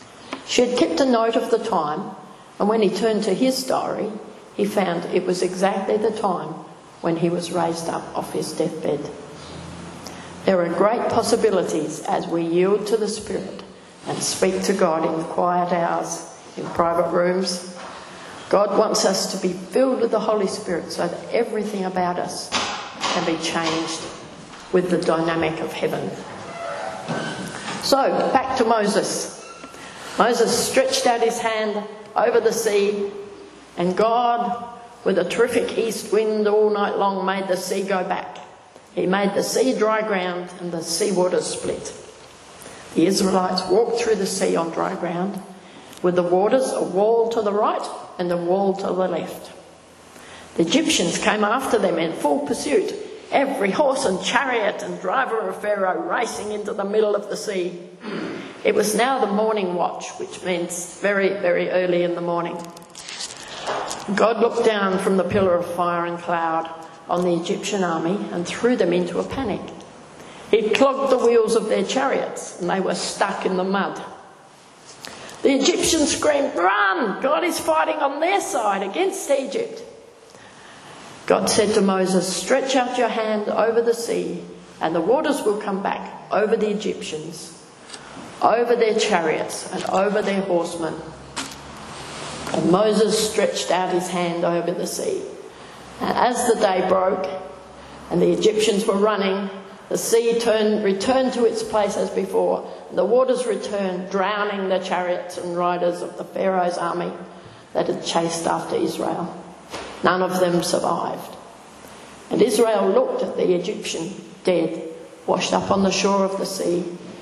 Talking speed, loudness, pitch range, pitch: 160 wpm, -21 LUFS, 180-230 Hz, 200 Hz